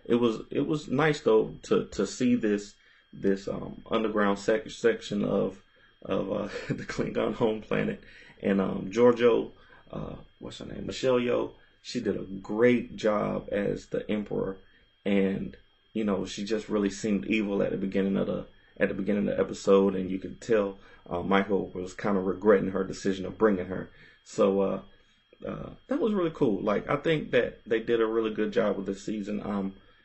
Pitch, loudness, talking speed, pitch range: 105 Hz, -28 LUFS, 190 wpm, 95-115 Hz